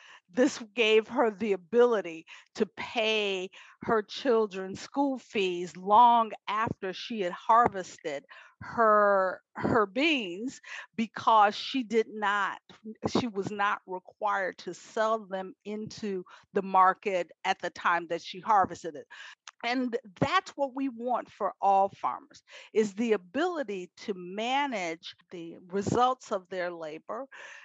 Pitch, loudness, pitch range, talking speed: 215 Hz, -29 LUFS, 190-235 Hz, 125 wpm